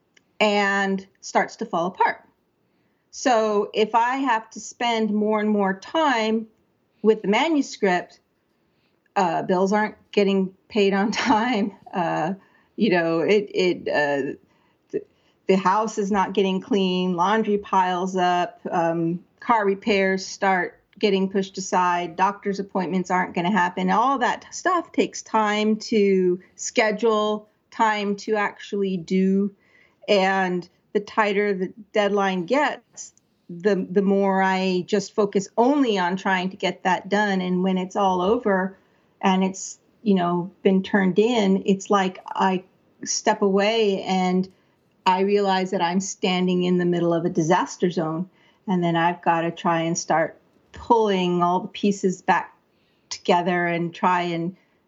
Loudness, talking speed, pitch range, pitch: -22 LUFS, 140 wpm, 185-215 Hz, 195 Hz